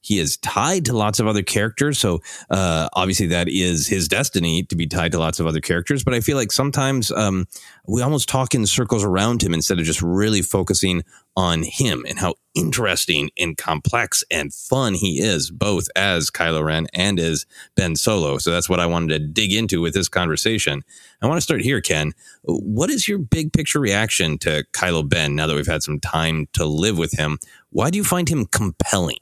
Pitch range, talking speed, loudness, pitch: 80-115 Hz, 210 wpm, -20 LUFS, 95 Hz